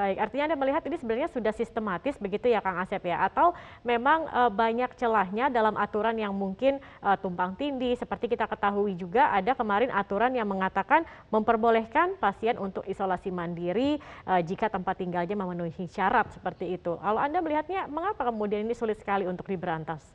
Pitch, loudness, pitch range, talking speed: 215 Hz, -28 LUFS, 190-245 Hz, 160 wpm